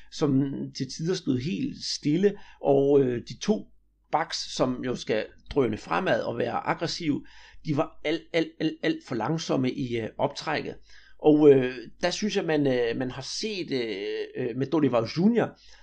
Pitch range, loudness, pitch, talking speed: 135-200 Hz, -27 LUFS, 155 Hz, 165 wpm